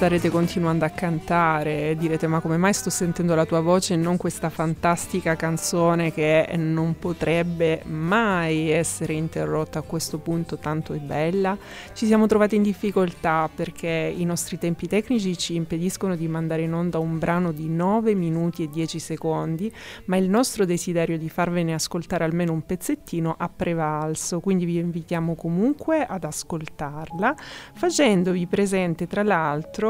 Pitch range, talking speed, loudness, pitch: 160-185 Hz, 150 wpm, -23 LUFS, 170 Hz